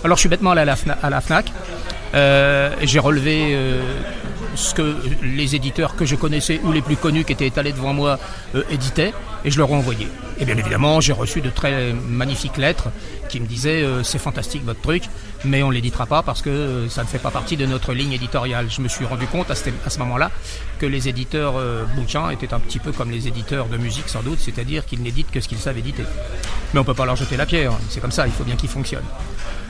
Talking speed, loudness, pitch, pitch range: 235 wpm, -20 LUFS, 135 Hz, 120-145 Hz